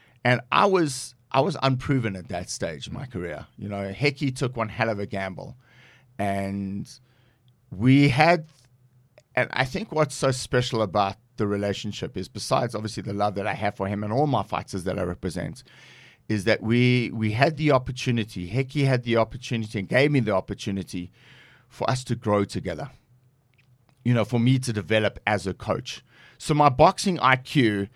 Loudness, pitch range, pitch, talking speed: -25 LUFS, 105-130 Hz, 120 Hz, 180 wpm